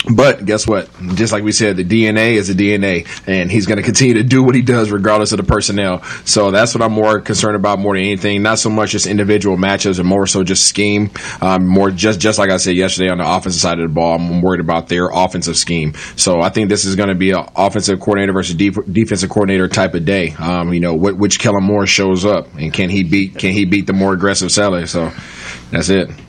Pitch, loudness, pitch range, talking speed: 100 Hz, -13 LUFS, 90-105 Hz, 250 wpm